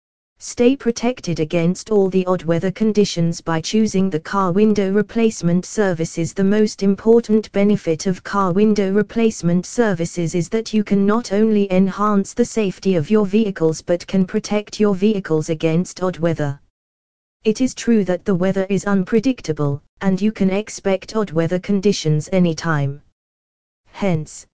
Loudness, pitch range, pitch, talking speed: -18 LUFS, 170-210 Hz, 195 Hz, 150 wpm